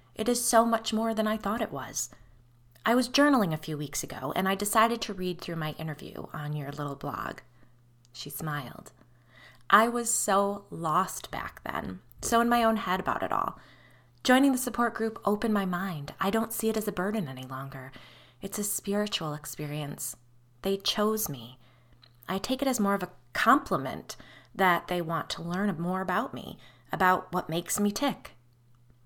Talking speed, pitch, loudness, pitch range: 185 wpm, 180 Hz, -29 LUFS, 130-215 Hz